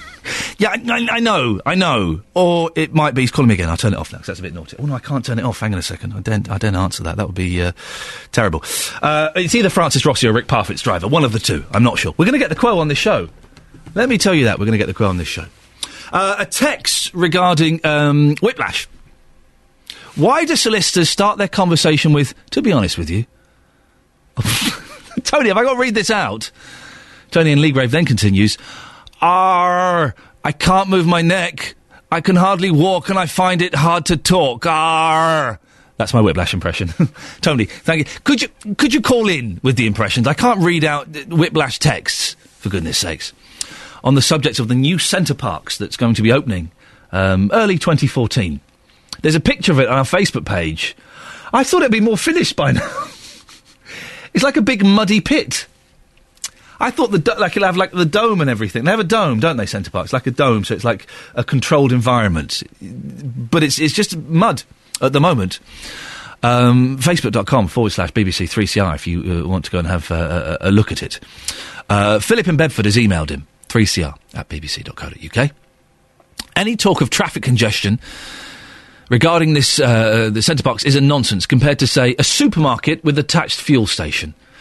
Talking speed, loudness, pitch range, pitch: 205 wpm, -15 LUFS, 105-175 Hz, 140 Hz